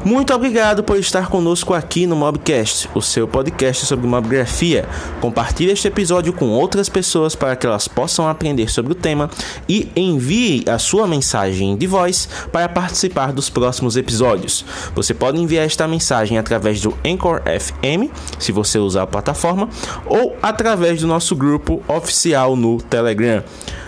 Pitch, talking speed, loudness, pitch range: 150 Hz, 155 wpm, -16 LUFS, 115-180 Hz